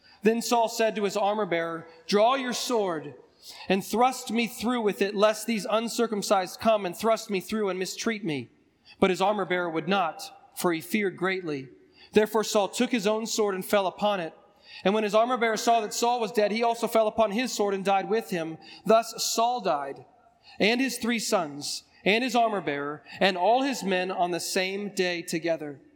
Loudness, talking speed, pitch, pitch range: -26 LUFS, 200 wpm, 210 Hz, 185-225 Hz